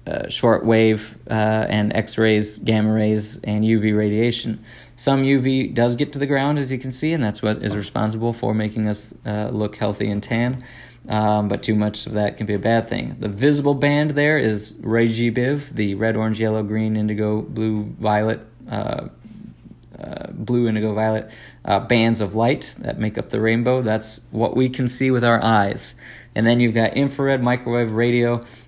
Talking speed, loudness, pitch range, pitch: 190 wpm, -20 LUFS, 105-125 Hz, 110 Hz